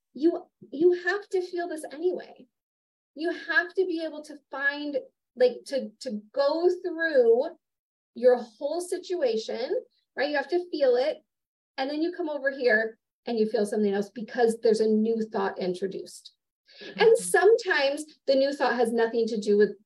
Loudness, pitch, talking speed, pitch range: -26 LUFS, 290 Hz, 165 wpm, 235-355 Hz